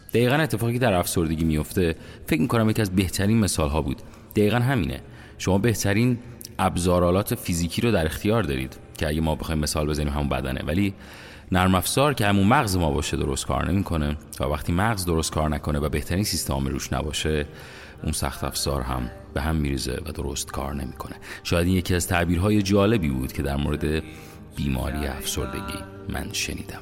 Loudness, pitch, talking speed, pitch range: -24 LUFS, 85 Hz, 175 wpm, 75-100 Hz